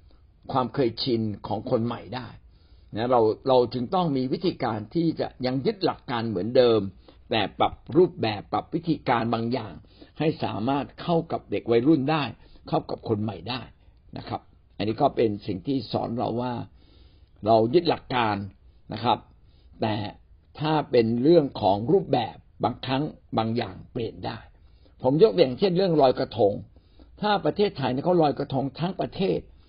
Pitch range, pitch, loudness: 105-140 Hz, 120 Hz, -25 LUFS